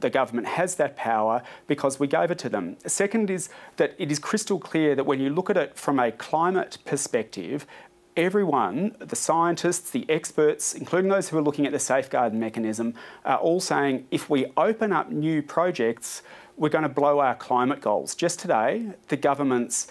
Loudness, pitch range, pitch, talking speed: -25 LUFS, 140-175 Hz, 155 Hz, 185 wpm